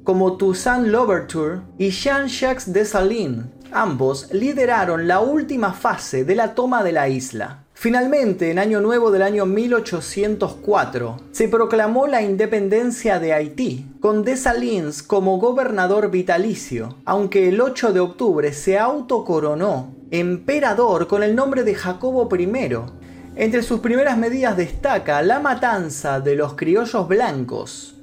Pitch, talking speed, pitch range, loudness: 200 Hz, 130 wpm, 170-240 Hz, -19 LUFS